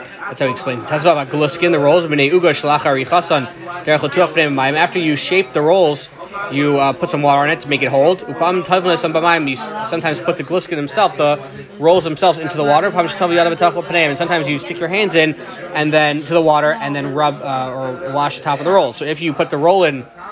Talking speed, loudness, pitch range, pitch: 200 wpm, -15 LUFS, 145-175 Hz, 160 Hz